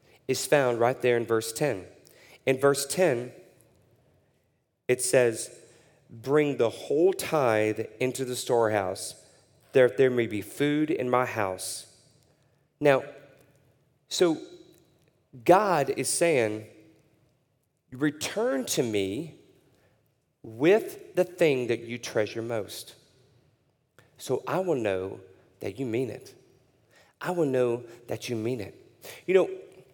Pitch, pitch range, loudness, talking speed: 130 Hz, 120-150 Hz, -27 LUFS, 120 wpm